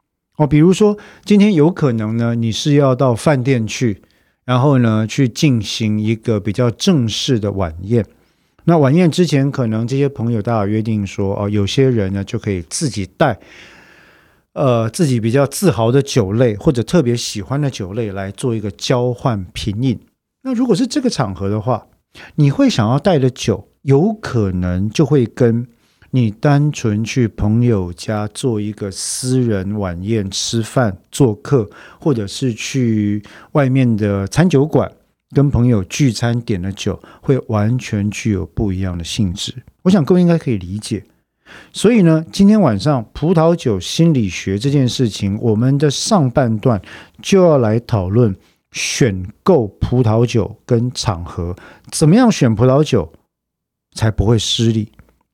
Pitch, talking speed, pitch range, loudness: 120 Hz, 230 characters per minute, 105-140 Hz, -16 LUFS